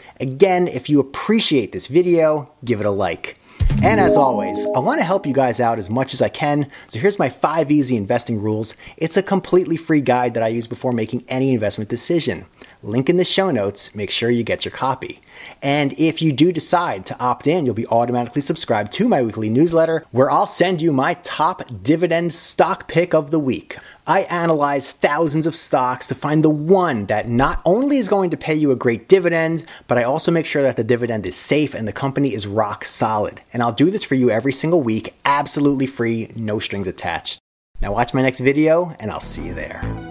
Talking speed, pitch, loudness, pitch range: 215 wpm, 140 Hz, -18 LUFS, 120-165 Hz